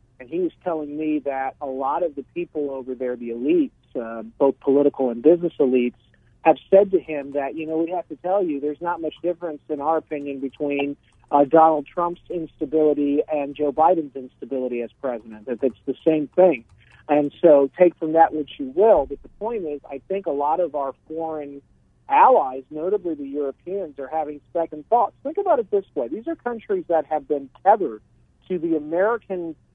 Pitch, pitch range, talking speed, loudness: 150 Hz, 140-175 Hz, 200 wpm, -22 LUFS